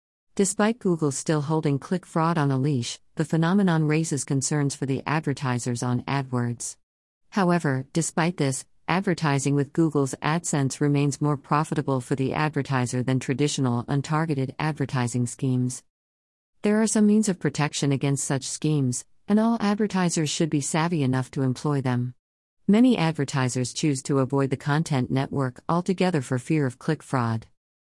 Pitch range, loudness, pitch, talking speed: 130-160 Hz, -25 LUFS, 140 Hz, 150 wpm